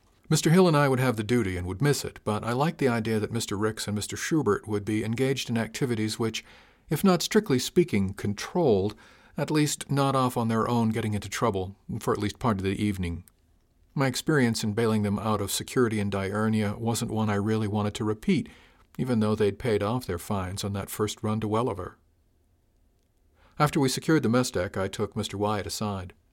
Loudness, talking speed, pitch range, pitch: -27 LUFS, 210 wpm, 100-125 Hz, 110 Hz